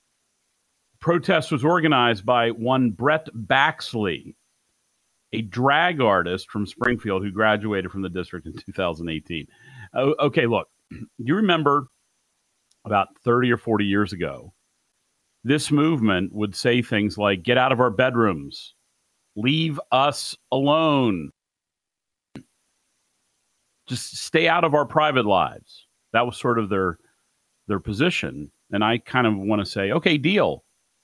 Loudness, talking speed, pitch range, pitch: -22 LUFS, 130 wpm, 100-140 Hz, 115 Hz